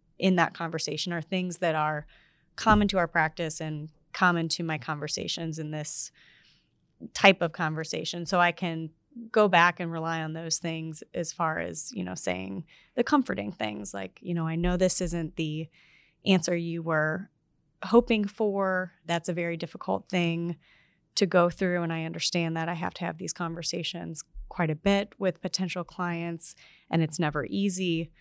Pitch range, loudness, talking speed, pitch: 160-180 Hz, -28 LUFS, 170 wpm, 170 Hz